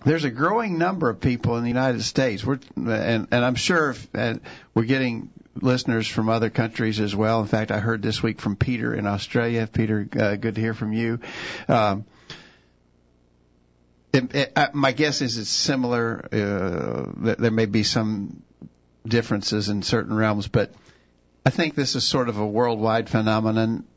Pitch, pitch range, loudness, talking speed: 115 Hz, 105-125 Hz, -23 LUFS, 180 wpm